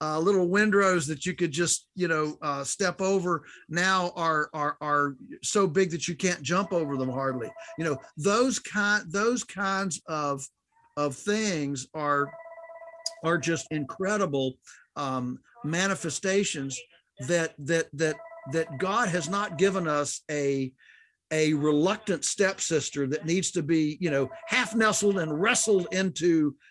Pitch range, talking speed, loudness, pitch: 150-195 Hz, 145 wpm, -27 LUFS, 170 Hz